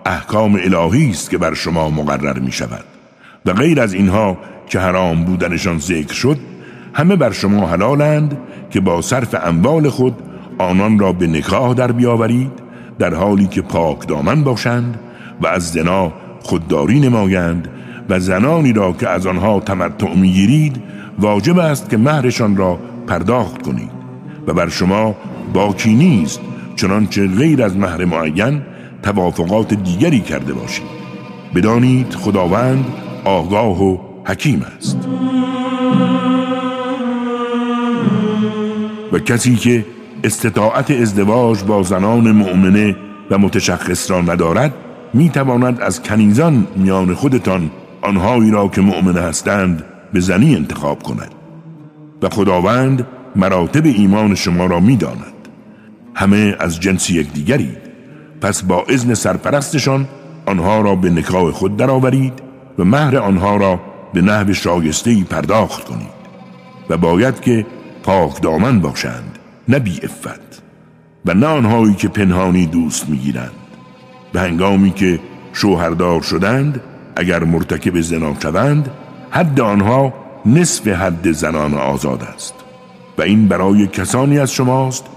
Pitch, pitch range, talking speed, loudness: 100 Hz, 90-125 Hz, 125 wpm, -14 LUFS